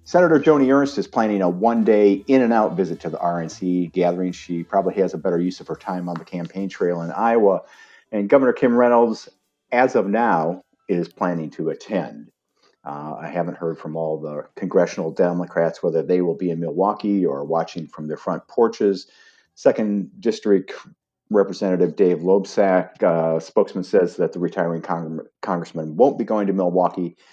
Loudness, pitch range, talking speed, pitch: -20 LUFS, 85-105 Hz, 170 wpm, 90 Hz